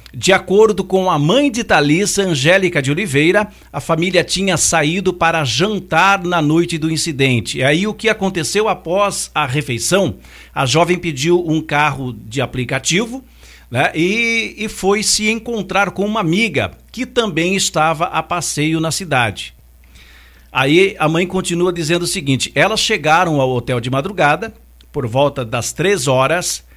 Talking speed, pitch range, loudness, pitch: 155 wpm, 145-195 Hz, -15 LUFS, 170 Hz